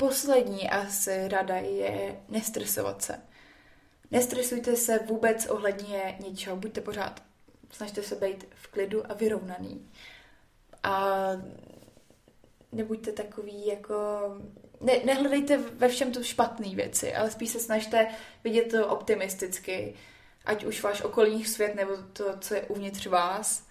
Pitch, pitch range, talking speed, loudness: 210 Hz, 195-225 Hz, 125 wpm, -29 LUFS